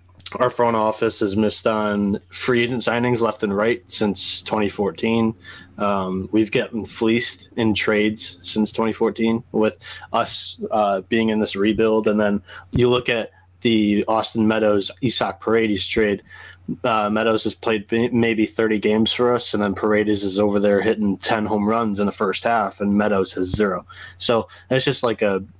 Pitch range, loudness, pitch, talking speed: 100-115 Hz, -20 LUFS, 110 Hz, 170 wpm